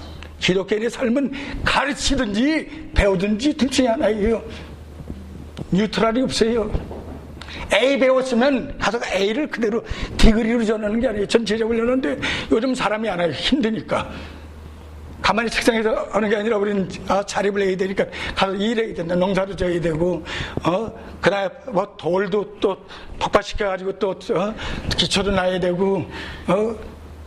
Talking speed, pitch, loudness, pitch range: 305 characters per minute, 205 Hz, -21 LUFS, 180-230 Hz